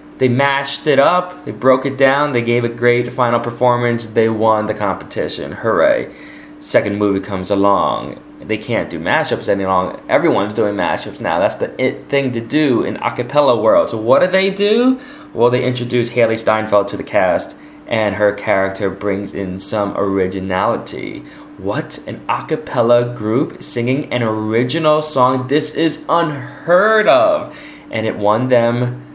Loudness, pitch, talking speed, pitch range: -16 LUFS, 120 Hz, 165 wpm, 105-140 Hz